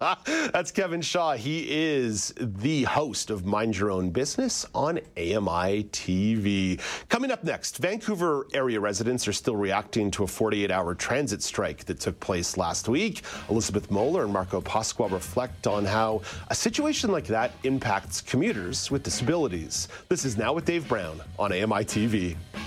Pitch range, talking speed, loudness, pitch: 100-135 Hz, 160 wpm, -27 LUFS, 110 Hz